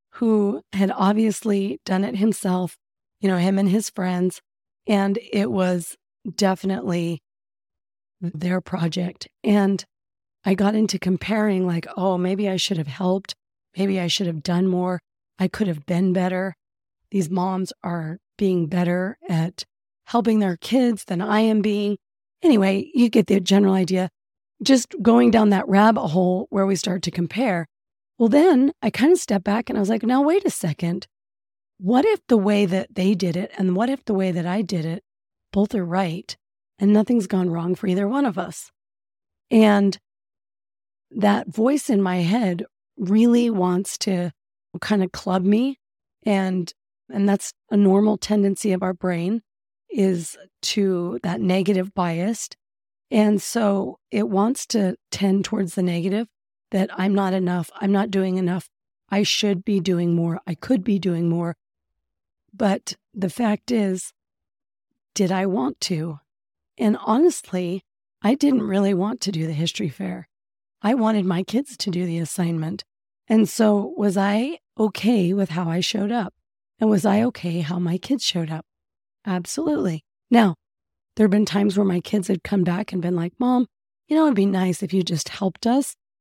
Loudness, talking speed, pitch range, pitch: -22 LUFS, 170 wpm, 180-215 Hz, 195 Hz